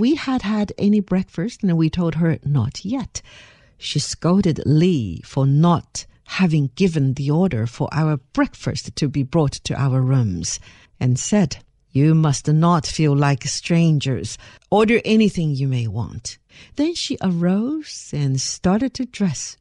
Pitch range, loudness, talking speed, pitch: 135-190 Hz, -20 LUFS, 150 wpm, 155 Hz